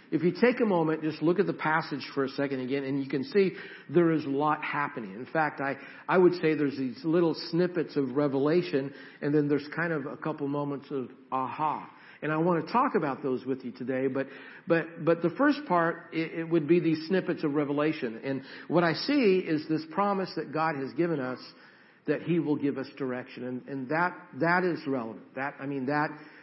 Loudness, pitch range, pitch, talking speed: -29 LUFS, 140-170 Hz, 155 Hz, 225 wpm